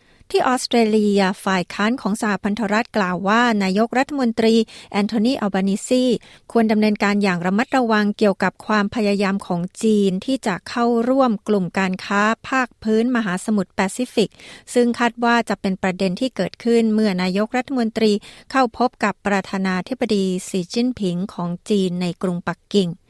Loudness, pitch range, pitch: -20 LUFS, 195-235 Hz, 210 Hz